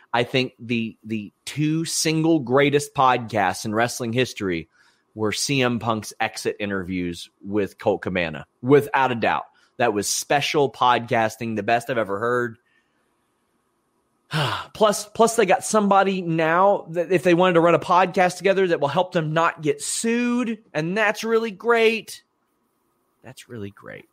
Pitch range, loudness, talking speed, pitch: 115-185 Hz, -21 LUFS, 150 wpm, 145 Hz